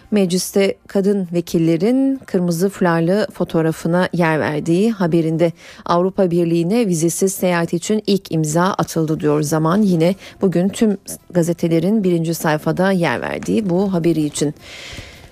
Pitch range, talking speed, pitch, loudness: 165-195 Hz, 120 wpm, 175 Hz, -17 LUFS